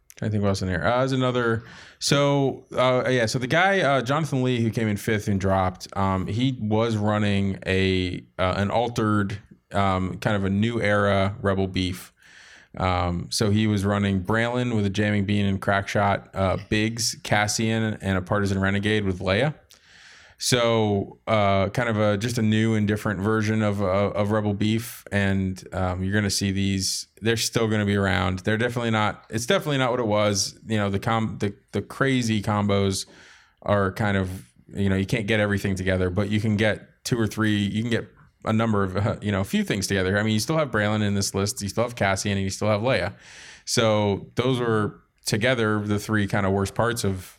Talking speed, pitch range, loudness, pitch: 210 wpm, 100-110 Hz, -24 LUFS, 105 Hz